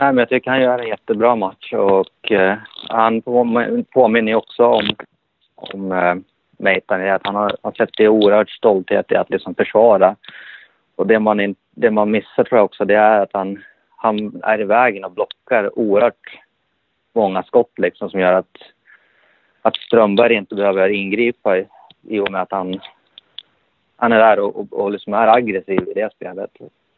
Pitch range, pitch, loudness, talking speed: 95-115 Hz, 105 Hz, -16 LUFS, 170 wpm